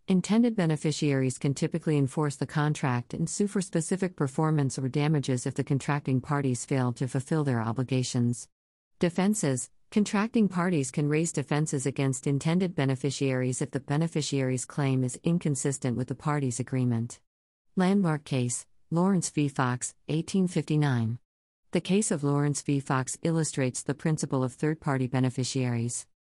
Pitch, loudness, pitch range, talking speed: 145 Hz, -28 LUFS, 130-160 Hz, 135 wpm